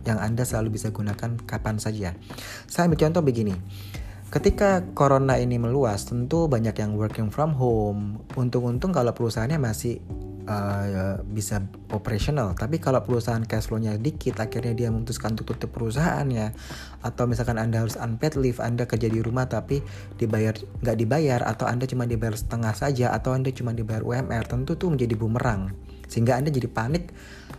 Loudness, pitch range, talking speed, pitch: -25 LUFS, 110-125 Hz, 160 wpm, 115 Hz